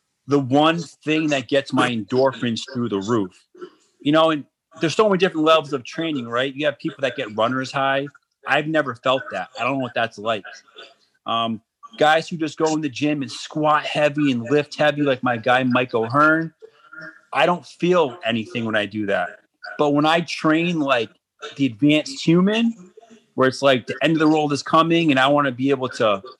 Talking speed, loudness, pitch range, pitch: 205 wpm, -20 LUFS, 130-160 Hz, 145 Hz